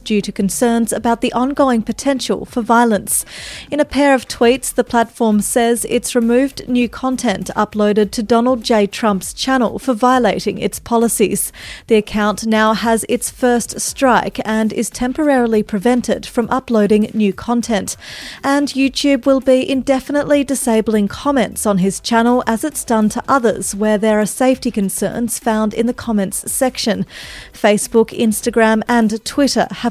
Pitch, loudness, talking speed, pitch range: 235 Hz, -16 LUFS, 155 wpm, 215-255 Hz